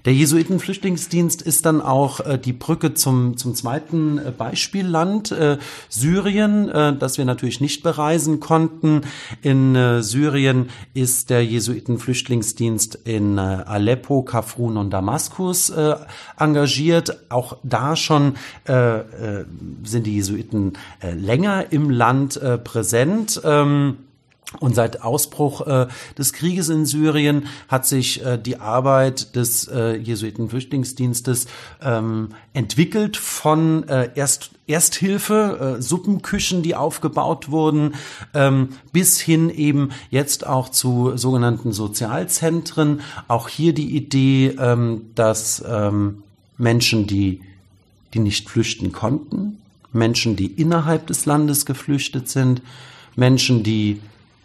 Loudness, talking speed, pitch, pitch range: -19 LUFS, 105 wpm, 130 Hz, 115-155 Hz